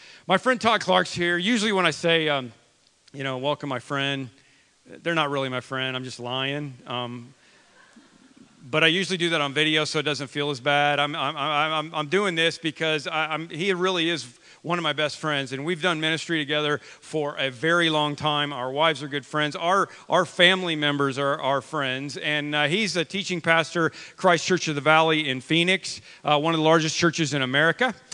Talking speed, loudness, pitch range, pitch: 205 wpm, -23 LUFS, 140-170 Hz, 155 Hz